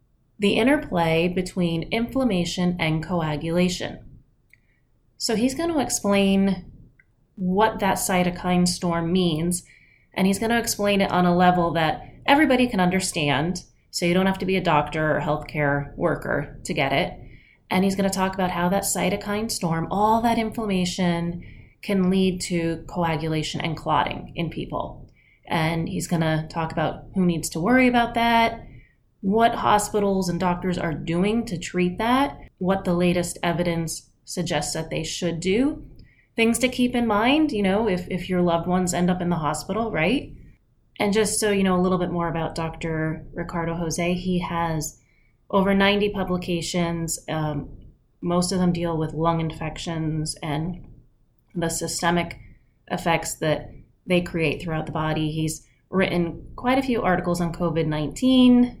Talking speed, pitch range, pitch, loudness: 160 wpm, 160-195 Hz, 175 Hz, -23 LUFS